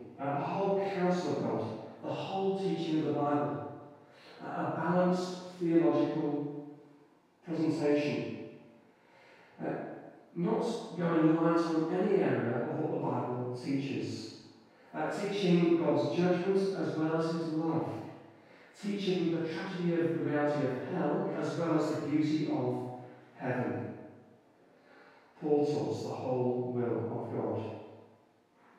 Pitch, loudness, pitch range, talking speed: 155 Hz, -32 LUFS, 145-175 Hz, 125 wpm